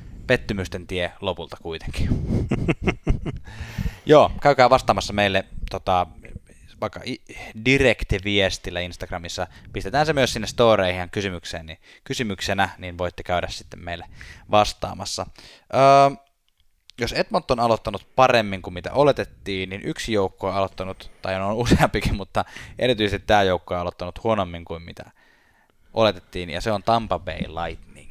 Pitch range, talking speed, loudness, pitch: 90-110 Hz, 130 wpm, -22 LUFS, 95 Hz